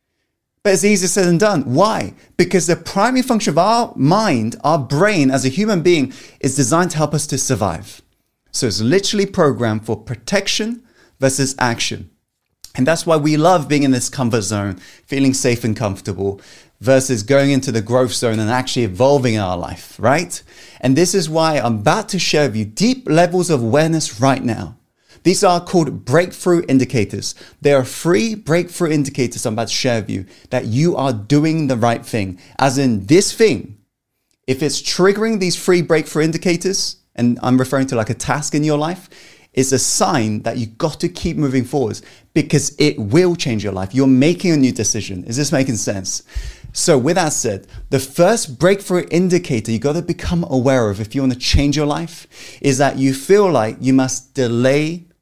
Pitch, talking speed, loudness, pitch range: 140 Hz, 190 wpm, -16 LUFS, 120-170 Hz